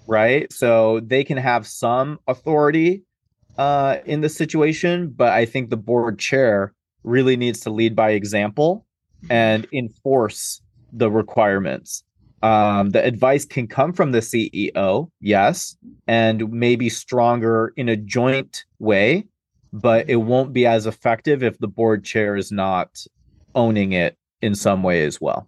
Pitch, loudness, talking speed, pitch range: 115 Hz, -19 LUFS, 145 wpm, 110-130 Hz